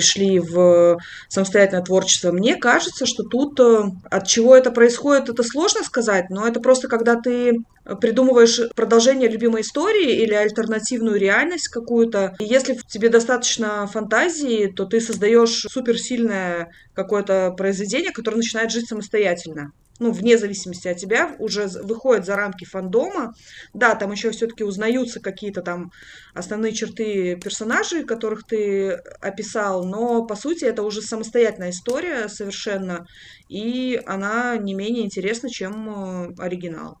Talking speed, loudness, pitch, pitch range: 130 wpm, -19 LUFS, 220 Hz, 195-235 Hz